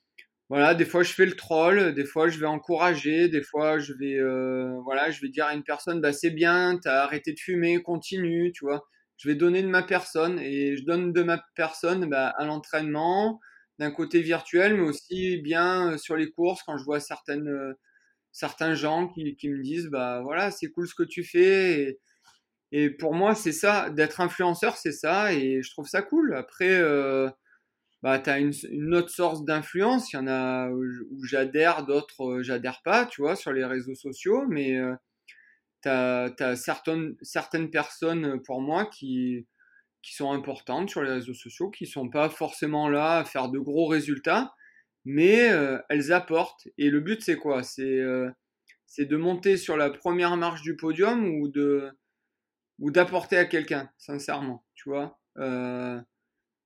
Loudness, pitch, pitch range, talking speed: -26 LUFS, 155 Hz, 140-175 Hz, 185 wpm